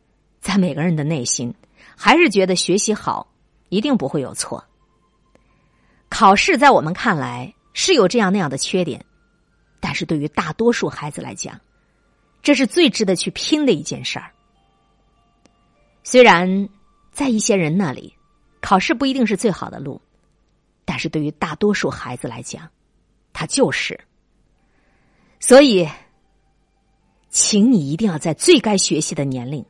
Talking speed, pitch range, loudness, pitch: 215 characters per minute, 160-235 Hz, -17 LUFS, 195 Hz